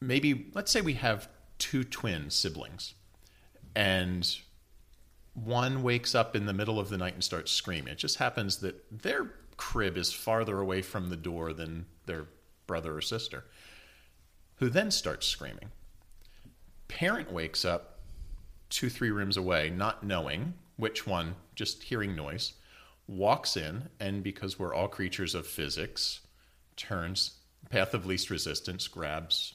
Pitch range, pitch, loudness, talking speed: 85-110 Hz, 95 Hz, -32 LUFS, 145 wpm